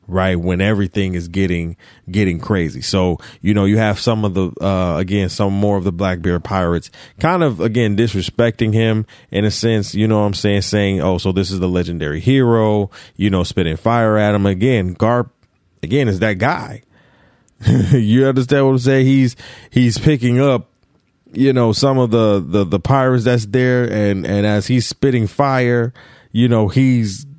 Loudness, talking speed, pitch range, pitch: -16 LUFS, 185 wpm, 95-120 Hz, 105 Hz